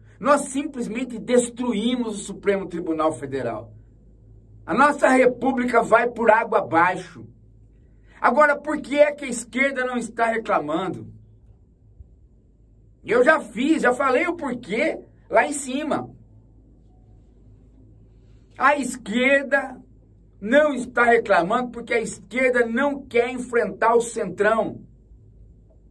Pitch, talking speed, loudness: 230 Hz, 110 wpm, -21 LUFS